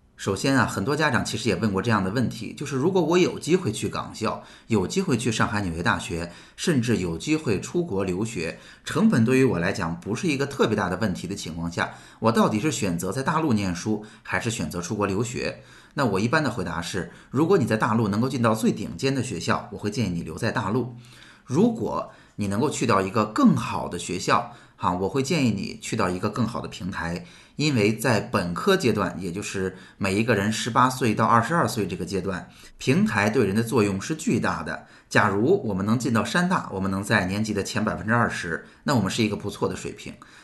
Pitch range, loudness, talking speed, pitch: 95-125 Hz, -24 LUFS, 325 characters per minute, 110 Hz